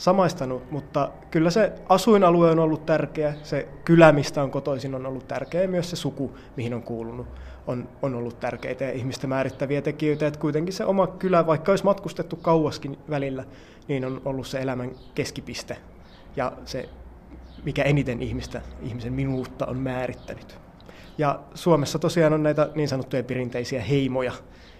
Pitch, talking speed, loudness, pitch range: 140 Hz, 155 wpm, -24 LUFS, 130-160 Hz